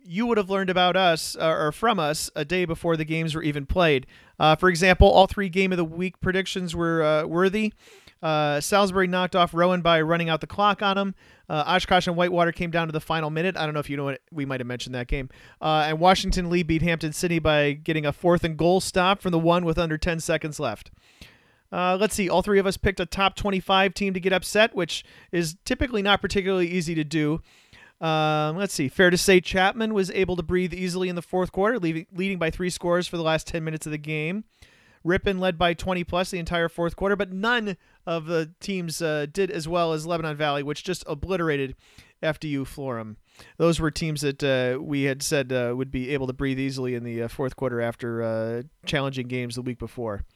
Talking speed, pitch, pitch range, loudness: 230 wpm, 170 Hz, 150-185 Hz, -24 LUFS